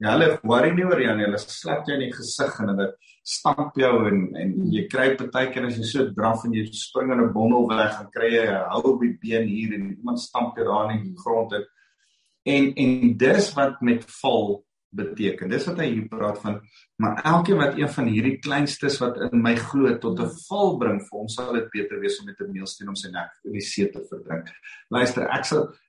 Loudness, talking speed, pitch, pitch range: -23 LUFS, 225 wpm, 120 Hz, 110-140 Hz